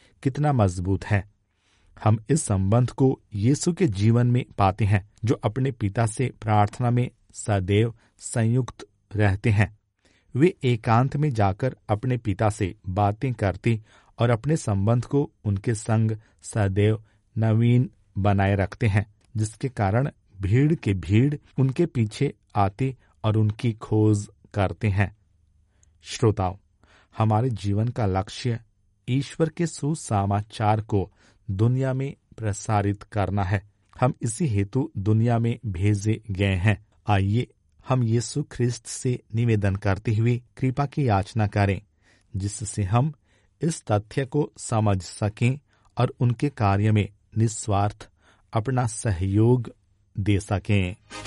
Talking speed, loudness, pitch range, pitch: 125 wpm, -25 LUFS, 100-125 Hz, 110 Hz